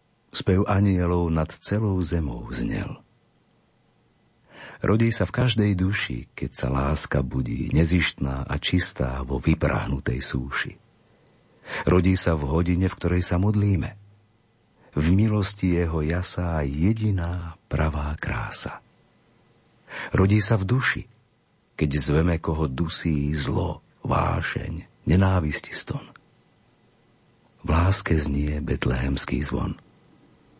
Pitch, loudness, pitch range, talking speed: 85 Hz, -24 LUFS, 75-100 Hz, 105 wpm